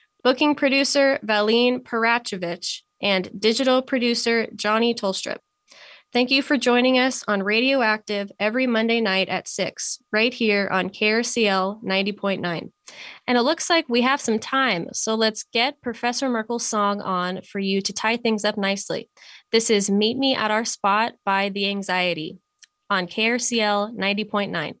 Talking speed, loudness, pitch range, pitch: 150 wpm, -21 LUFS, 200-250 Hz, 220 Hz